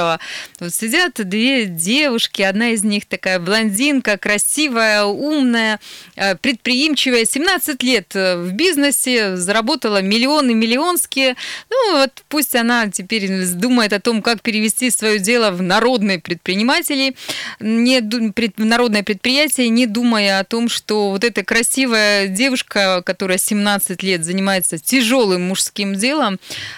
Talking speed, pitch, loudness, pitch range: 115 wpm, 225 Hz, -16 LUFS, 200-255 Hz